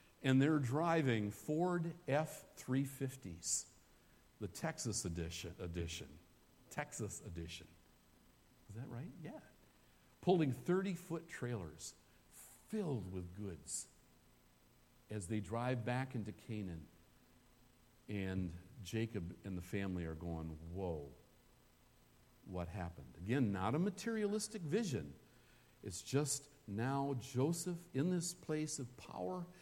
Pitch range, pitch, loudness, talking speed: 90-150 Hz, 115 Hz, -41 LUFS, 105 wpm